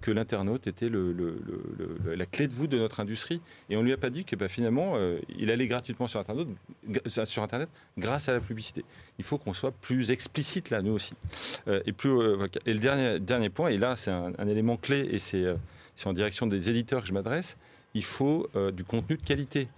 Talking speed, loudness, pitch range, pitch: 245 wpm, -31 LUFS, 100-130 Hz, 115 Hz